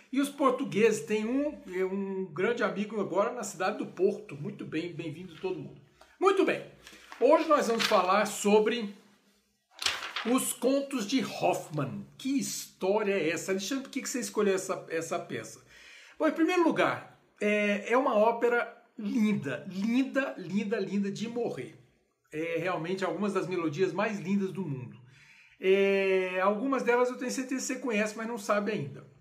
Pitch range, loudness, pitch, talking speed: 190-245 Hz, -30 LUFS, 210 Hz, 155 wpm